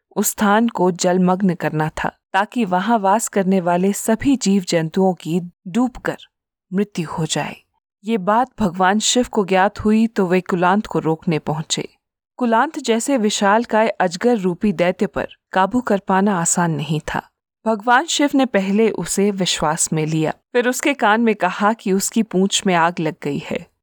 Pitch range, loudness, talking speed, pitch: 180-225 Hz, -18 LUFS, 165 wpm, 195 Hz